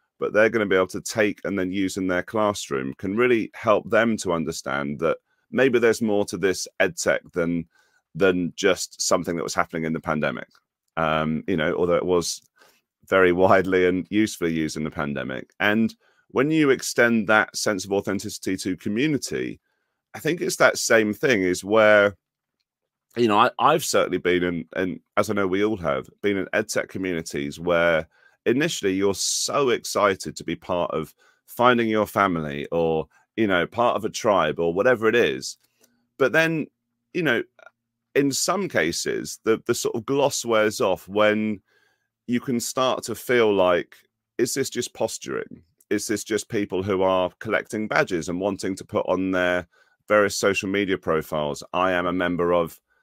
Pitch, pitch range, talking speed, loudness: 95 Hz, 85-110 Hz, 180 wpm, -23 LUFS